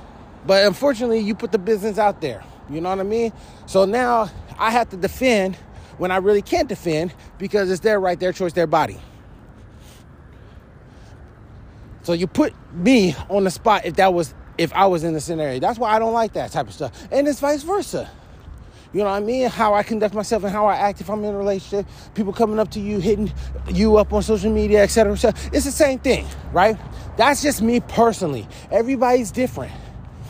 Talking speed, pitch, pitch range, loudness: 210 wpm, 205 Hz, 180-230 Hz, -20 LUFS